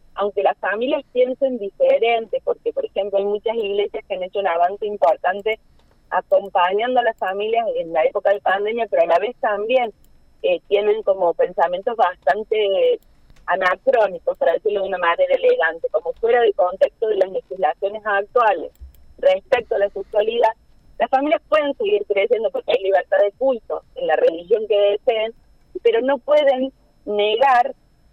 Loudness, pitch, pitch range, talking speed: -19 LUFS, 230 Hz, 200-300 Hz, 160 wpm